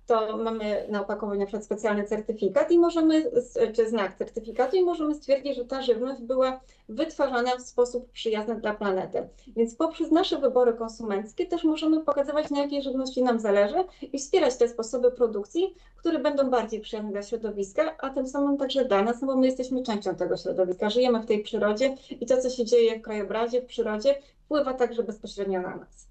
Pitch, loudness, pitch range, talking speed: 245 Hz, -26 LUFS, 220-280 Hz, 180 wpm